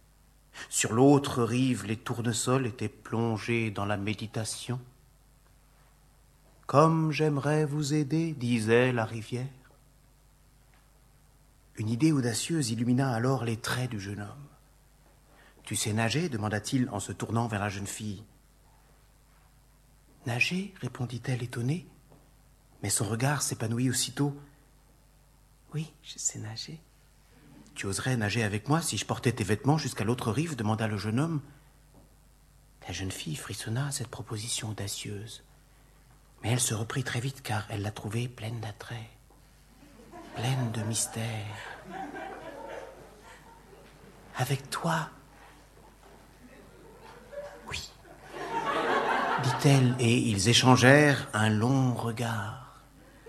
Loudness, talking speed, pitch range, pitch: -29 LUFS, 115 wpm, 110-140 Hz, 125 Hz